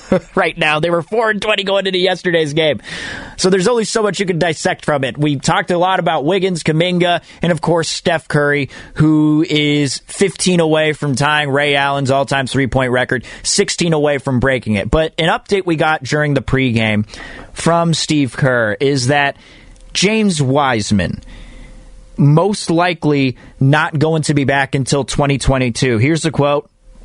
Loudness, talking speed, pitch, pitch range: -15 LUFS, 170 wpm, 150 Hz, 135-175 Hz